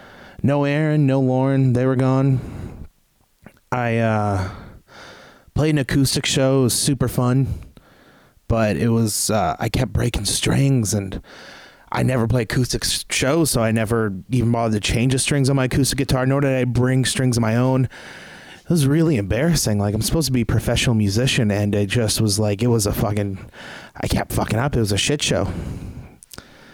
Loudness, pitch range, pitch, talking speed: -19 LUFS, 110-135 Hz, 125 Hz, 185 wpm